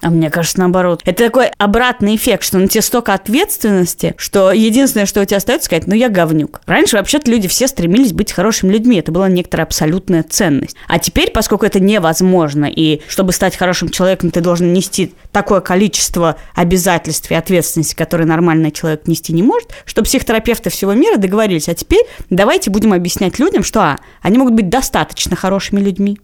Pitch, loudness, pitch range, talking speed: 190 Hz, -13 LUFS, 170-220 Hz, 180 wpm